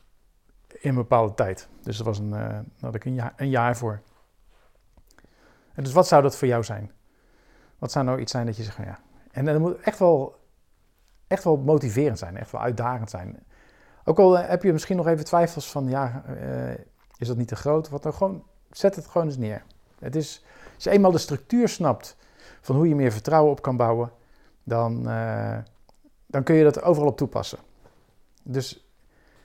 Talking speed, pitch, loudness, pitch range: 205 wpm, 130 Hz, -24 LUFS, 115-155 Hz